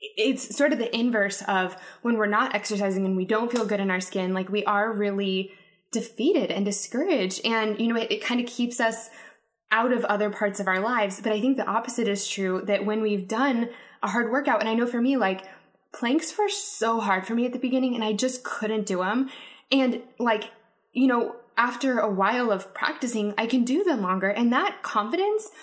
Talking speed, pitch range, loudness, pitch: 220 wpm, 205-255 Hz, -25 LUFS, 225 Hz